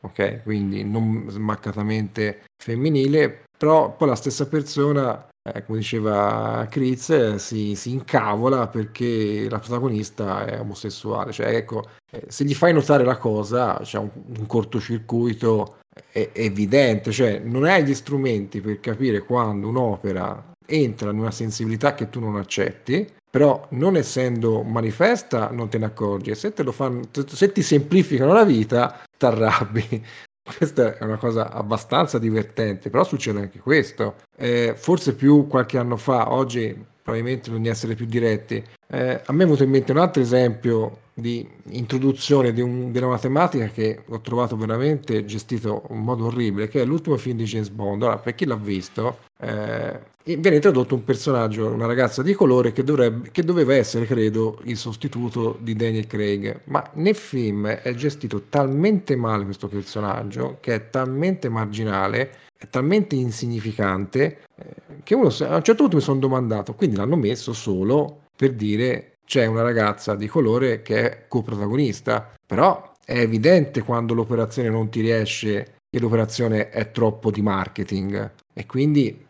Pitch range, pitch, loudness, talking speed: 110-135 Hz, 120 Hz, -22 LUFS, 160 wpm